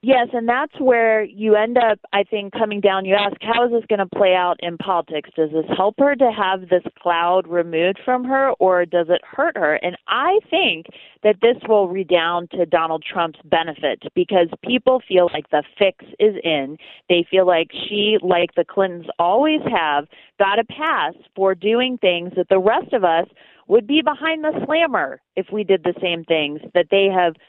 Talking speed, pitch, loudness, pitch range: 200 wpm, 195 Hz, -18 LUFS, 175-235 Hz